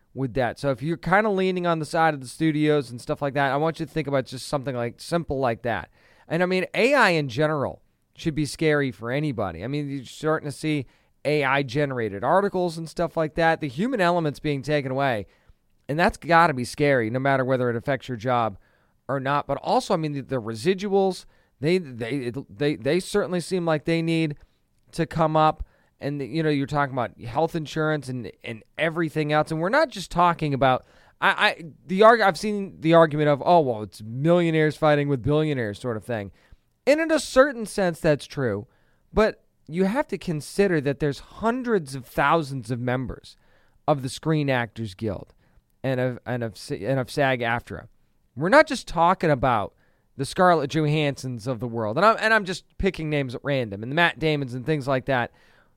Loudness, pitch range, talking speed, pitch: -24 LUFS, 130-165 Hz, 205 wpm, 150 Hz